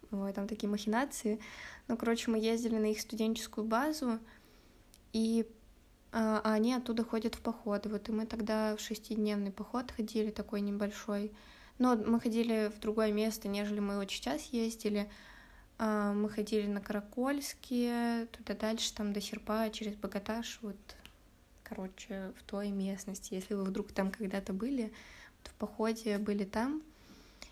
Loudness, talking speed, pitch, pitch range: -36 LUFS, 145 wpm, 215 Hz, 205-230 Hz